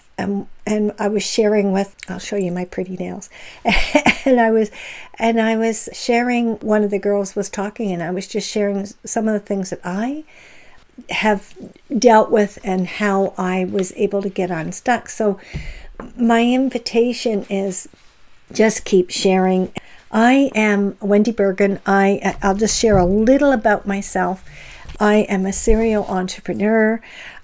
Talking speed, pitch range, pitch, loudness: 155 wpm, 195-225 Hz, 205 Hz, -18 LUFS